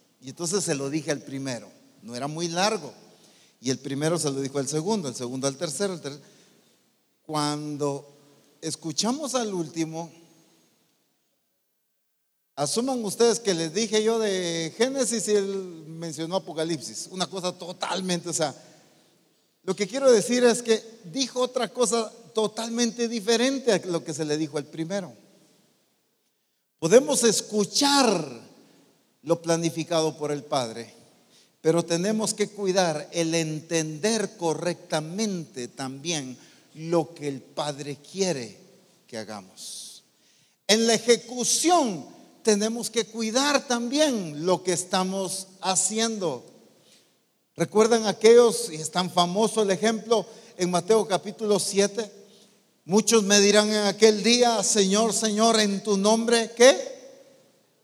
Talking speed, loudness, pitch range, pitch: 125 wpm, -24 LUFS, 160-225 Hz, 190 Hz